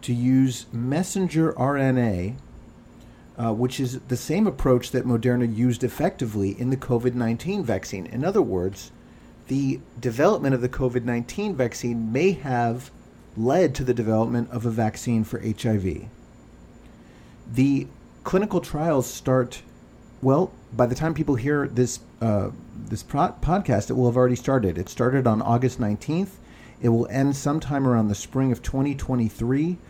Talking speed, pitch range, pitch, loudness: 145 wpm, 115-135 Hz, 125 Hz, -24 LUFS